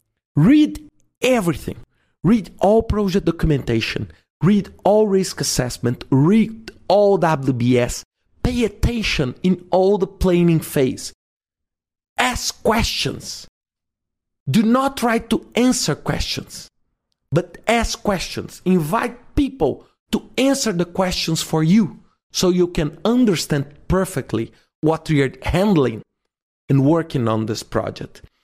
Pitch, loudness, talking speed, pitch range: 170 Hz, -19 LUFS, 110 wpm, 135-210 Hz